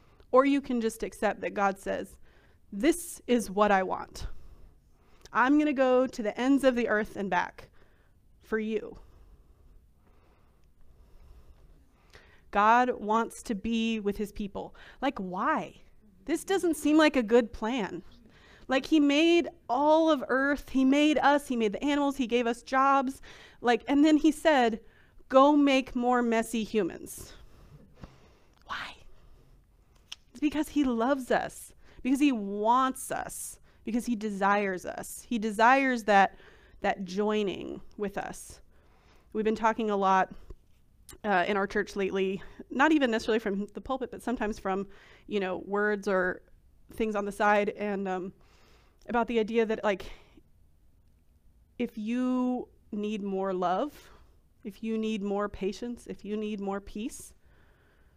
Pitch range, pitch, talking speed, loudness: 190-255 Hz, 220 Hz, 145 wpm, -28 LUFS